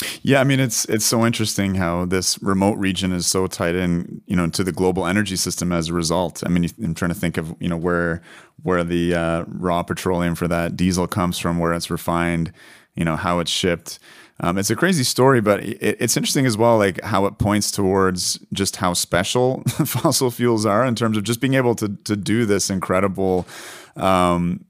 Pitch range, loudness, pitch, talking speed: 85-110 Hz, -20 LUFS, 95 Hz, 210 wpm